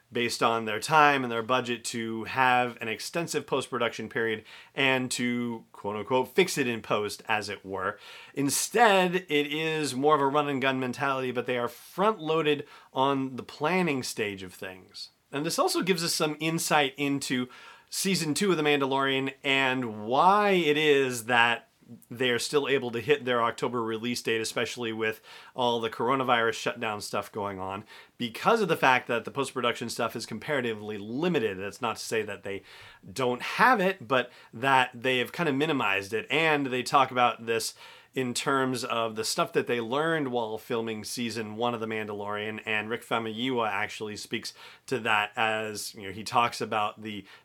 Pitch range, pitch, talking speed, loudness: 110-140 Hz, 125 Hz, 180 wpm, -27 LUFS